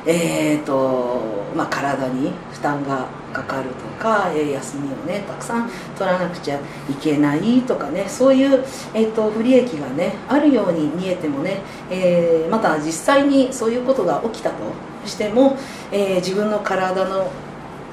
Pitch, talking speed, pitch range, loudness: 185 Hz, 295 characters per minute, 150-225 Hz, -20 LUFS